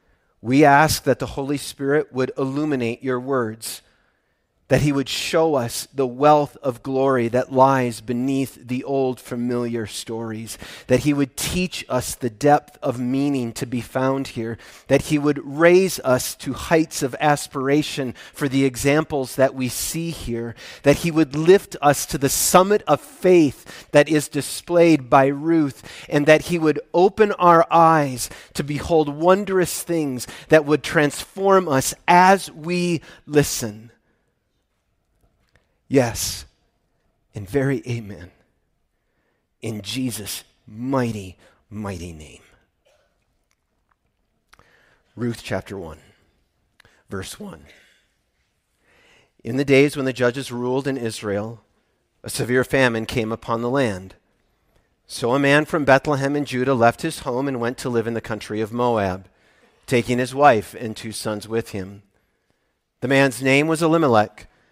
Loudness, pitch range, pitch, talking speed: -20 LUFS, 115-150 Hz, 135 Hz, 140 wpm